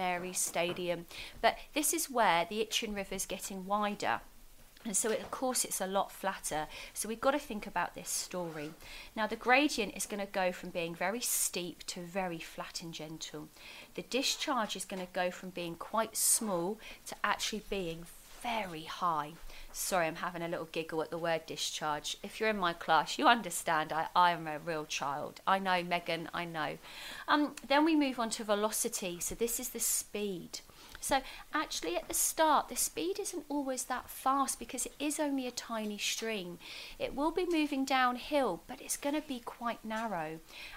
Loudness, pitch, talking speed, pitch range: -34 LUFS, 210 Hz, 195 wpm, 175-255 Hz